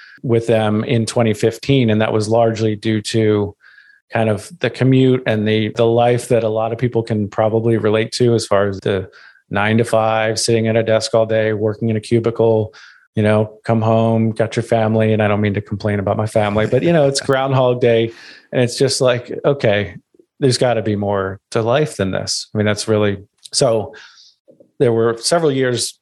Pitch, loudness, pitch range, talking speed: 115 Hz, -16 LUFS, 110-120 Hz, 205 wpm